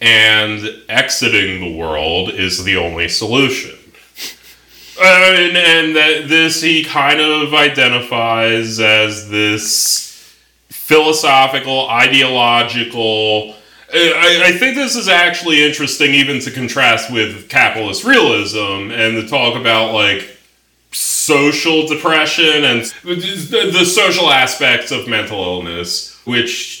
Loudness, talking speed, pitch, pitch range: -11 LUFS, 105 wpm, 130 Hz, 110-155 Hz